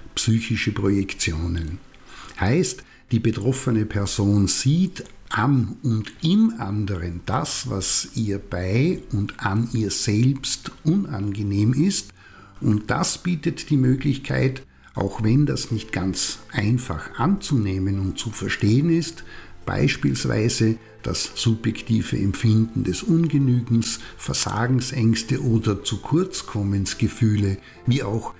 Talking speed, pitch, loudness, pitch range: 105 wpm, 115 Hz, -22 LUFS, 100-130 Hz